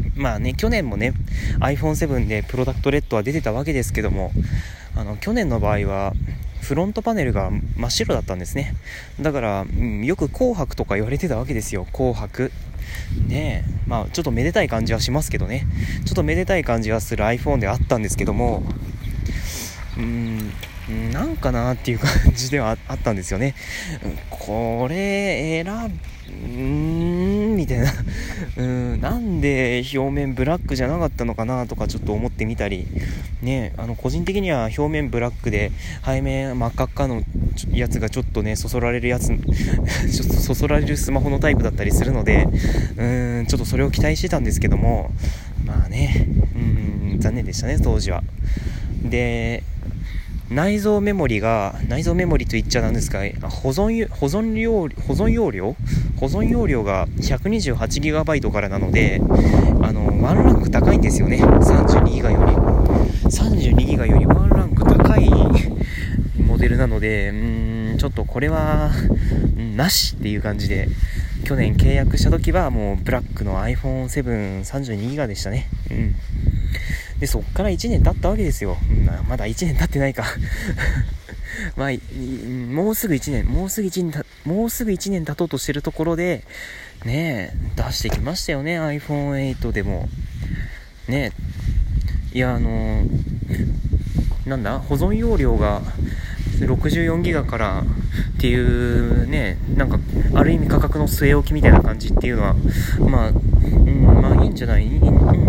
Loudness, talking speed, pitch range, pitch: -20 LUFS, 305 characters per minute, 100-135 Hz, 115 Hz